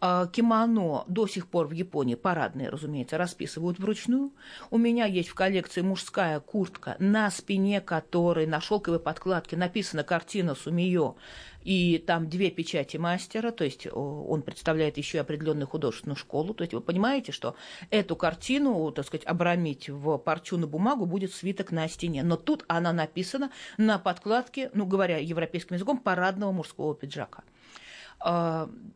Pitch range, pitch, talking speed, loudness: 160-200 Hz, 175 Hz, 145 wpm, -29 LUFS